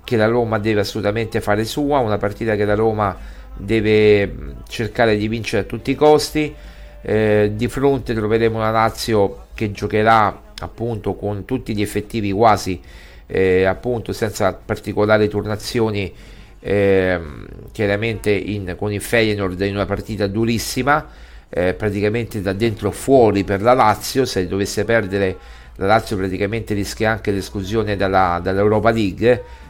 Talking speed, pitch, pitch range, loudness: 140 wpm, 105 Hz, 100-115 Hz, -18 LUFS